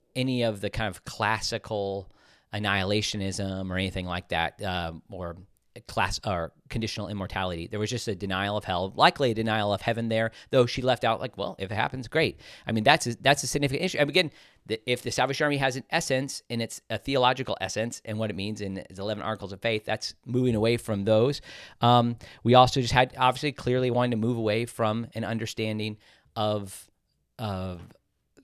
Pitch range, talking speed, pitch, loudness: 100-125 Hz, 195 wpm, 110 Hz, -27 LUFS